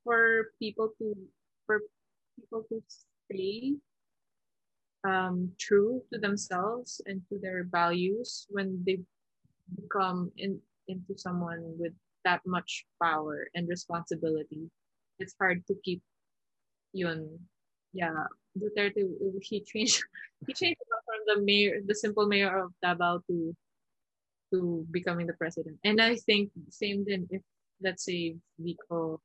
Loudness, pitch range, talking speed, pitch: -31 LUFS, 175-210 Hz, 125 wpm, 190 Hz